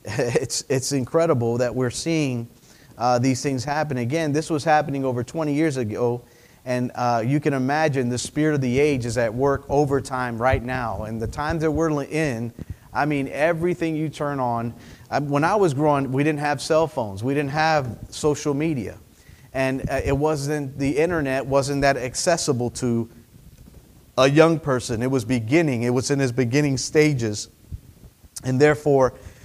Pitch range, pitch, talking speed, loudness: 120-150 Hz, 135 Hz, 175 wpm, -22 LUFS